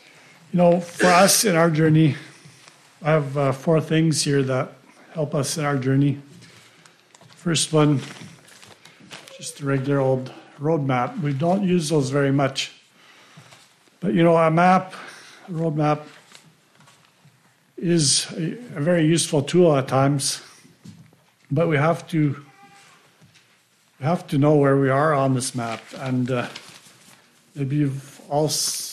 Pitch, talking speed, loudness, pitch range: 150 Hz, 135 wpm, -21 LUFS, 140-165 Hz